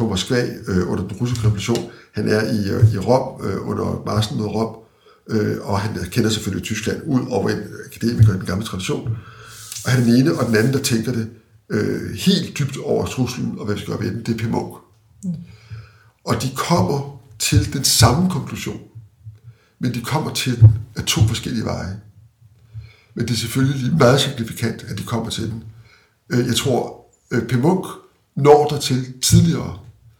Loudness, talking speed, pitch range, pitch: -19 LUFS, 180 wpm, 110-125 Hz, 115 Hz